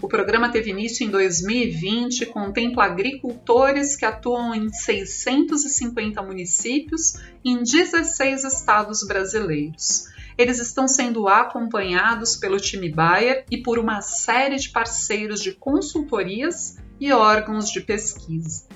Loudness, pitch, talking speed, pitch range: -21 LUFS, 235 Hz, 120 wpm, 210-265 Hz